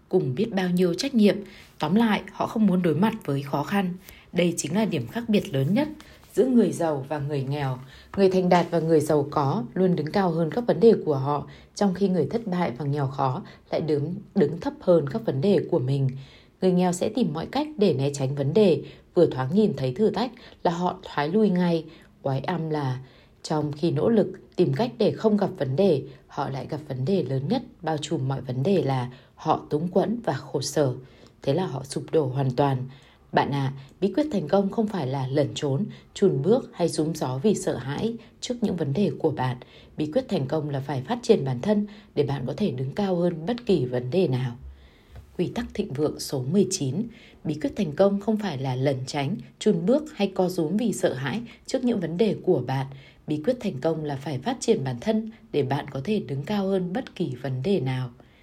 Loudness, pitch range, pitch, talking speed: -25 LUFS, 140-205 Hz, 170 Hz, 230 wpm